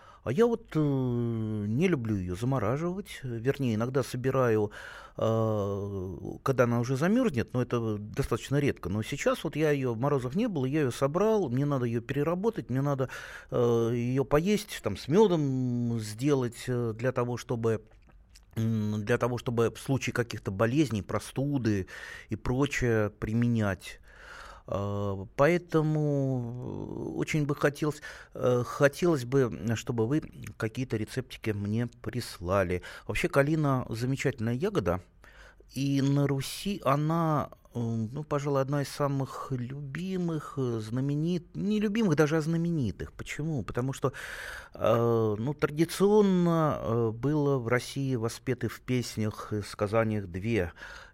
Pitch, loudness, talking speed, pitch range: 125 Hz, -29 LUFS, 125 wpm, 115-145 Hz